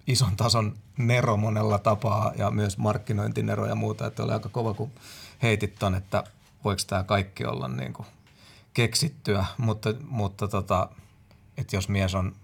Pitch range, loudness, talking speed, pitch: 100-115 Hz, -27 LUFS, 150 wpm, 105 Hz